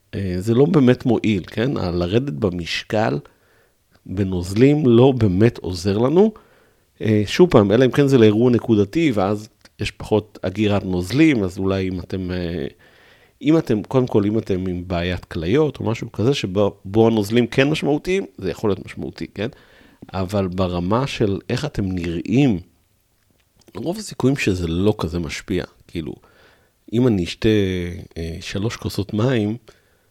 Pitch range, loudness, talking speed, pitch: 95-125 Hz, -19 LUFS, 140 wpm, 105 Hz